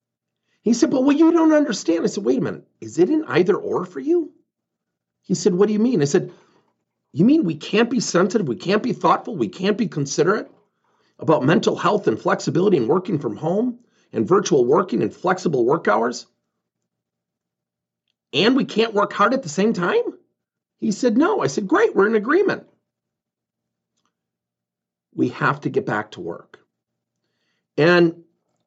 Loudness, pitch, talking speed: -19 LUFS, 205 Hz, 175 wpm